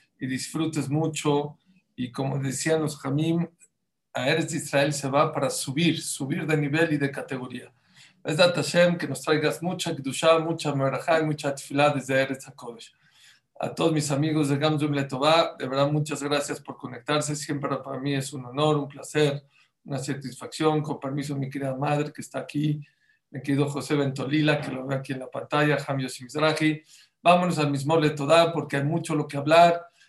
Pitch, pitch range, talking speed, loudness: 145 Hz, 140-155 Hz, 180 wpm, -25 LUFS